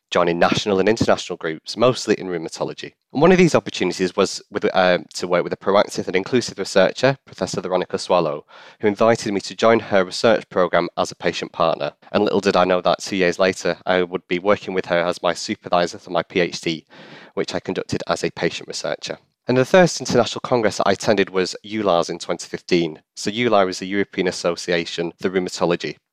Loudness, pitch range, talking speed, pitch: -20 LUFS, 90-110 Hz, 195 wpm, 95 Hz